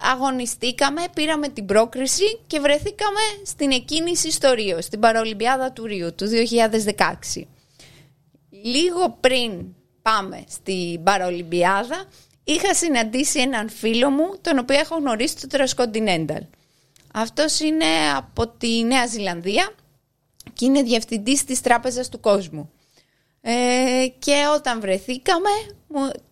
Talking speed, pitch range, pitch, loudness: 110 wpm, 195-290 Hz, 245 Hz, -21 LUFS